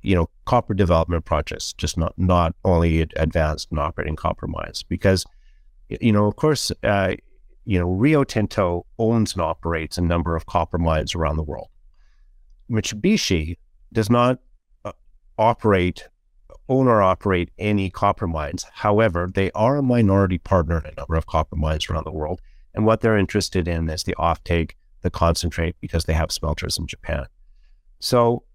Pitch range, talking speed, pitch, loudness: 80-105 Hz, 165 wpm, 90 Hz, -21 LUFS